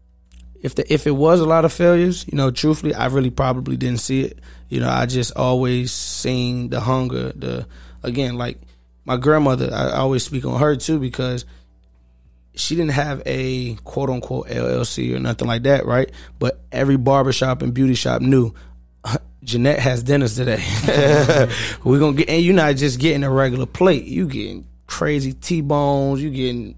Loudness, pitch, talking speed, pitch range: -19 LUFS, 130 Hz, 175 wpm, 100-140 Hz